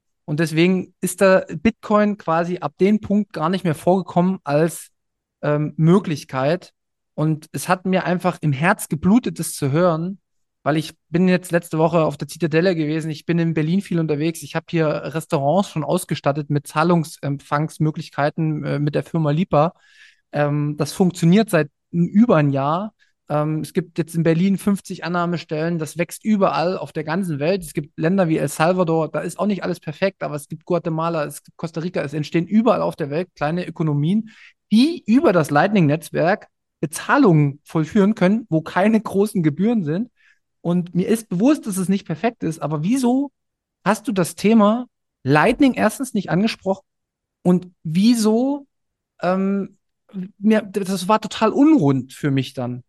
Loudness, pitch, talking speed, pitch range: -20 LUFS, 170 Hz, 165 wpm, 155-195 Hz